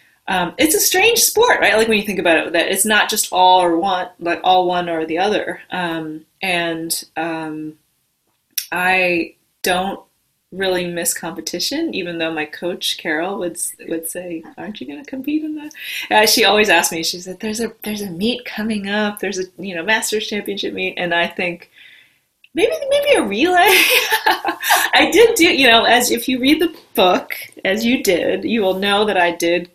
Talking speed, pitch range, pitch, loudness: 190 wpm, 170-235 Hz, 190 Hz, -16 LUFS